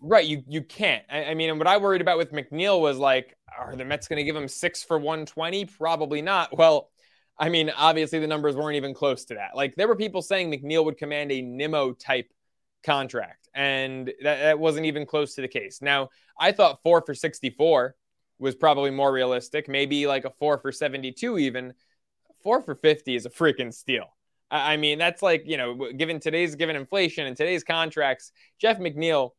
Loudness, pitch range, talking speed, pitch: -24 LUFS, 140-165 Hz, 205 wpm, 150 Hz